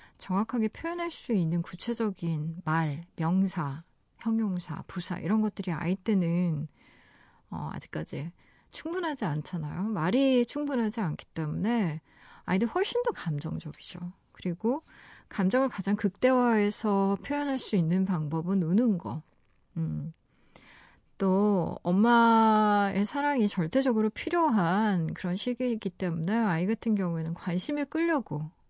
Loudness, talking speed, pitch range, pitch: -29 LUFS, 270 characters per minute, 170-230 Hz, 195 Hz